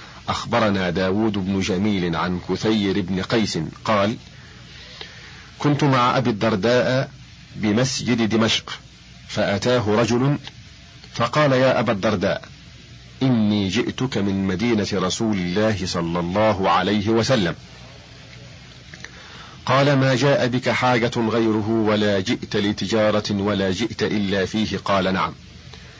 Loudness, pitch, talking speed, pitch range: -20 LUFS, 105 Hz, 105 wpm, 95-120 Hz